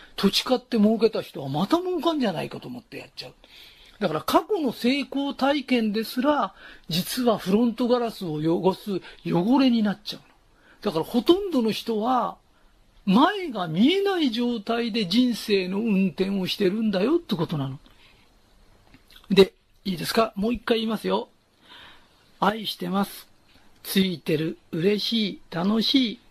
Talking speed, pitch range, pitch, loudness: 295 characters per minute, 185-245 Hz, 215 Hz, -24 LUFS